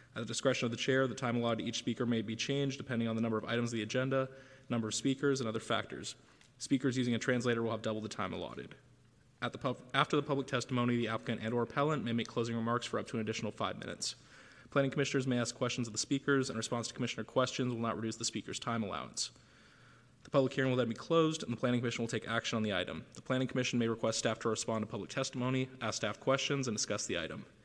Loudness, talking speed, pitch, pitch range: -35 LUFS, 255 wpm, 120 Hz, 115-130 Hz